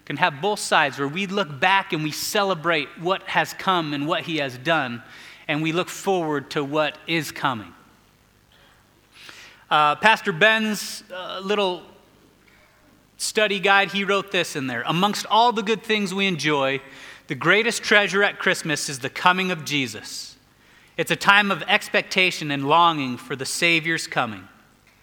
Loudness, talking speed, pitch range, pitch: -21 LUFS, 160 wpm, 150-200 Hz, 175 Hz